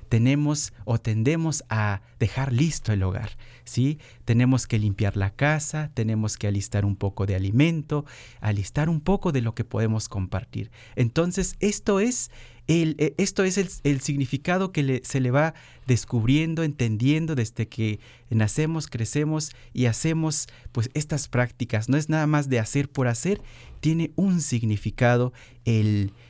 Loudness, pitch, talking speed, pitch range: -25 LUFS, 125 Hz, 150 wpm, 115-150 Hz